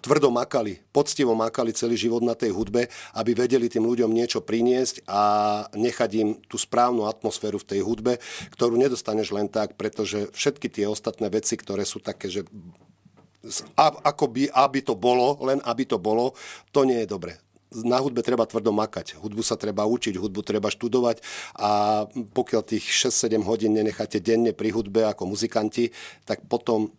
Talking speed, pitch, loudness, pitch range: 170 wpm, 115 Hz, -24 LUFS, 110-120 Hz